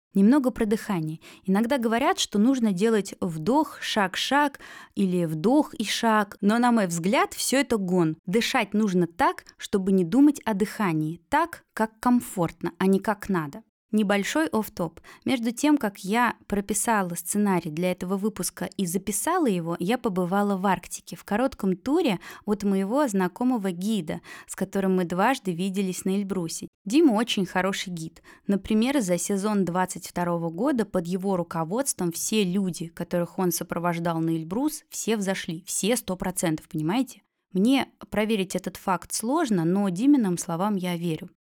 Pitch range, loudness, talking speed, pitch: 180-230 Hz, -25 LUFS, 150 wpm, 200 Hz